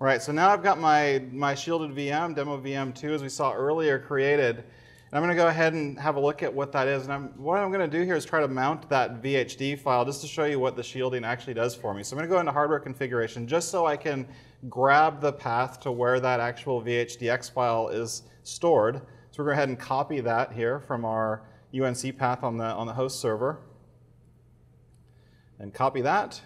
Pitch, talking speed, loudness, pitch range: 135 Hz, 235 wpm, -27 LUFS, 125-150 Hz